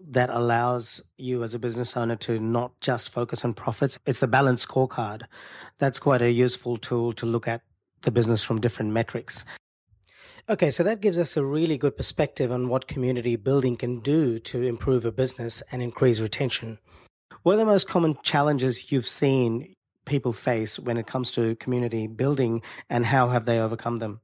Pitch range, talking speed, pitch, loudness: 115-135 Hz, 185 wpm, 125 Hz, -25 LUFS